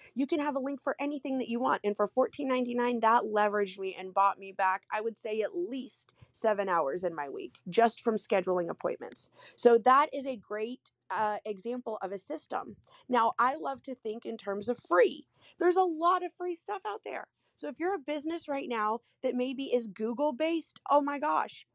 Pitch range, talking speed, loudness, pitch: 210-290 Hz, 210 wpm, -31 LUFS, 245 Hz